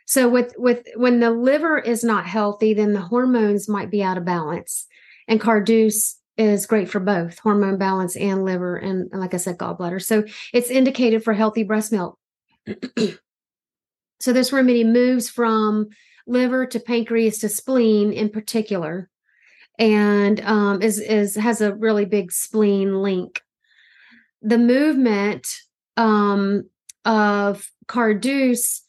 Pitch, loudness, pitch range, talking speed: 215 Hz, -20 LUFS, 200-235 Hz, 135 wpm